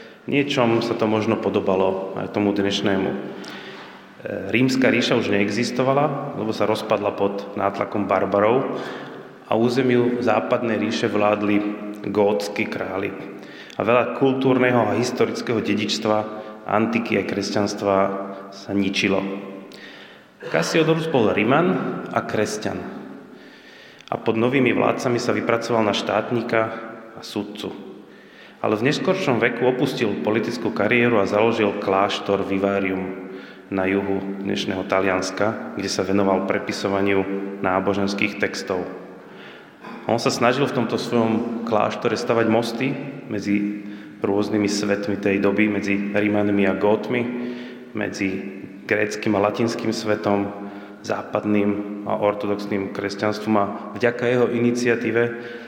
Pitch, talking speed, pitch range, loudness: 105 Hz, 110 wpm, 100-115 Hz, -21 LUFS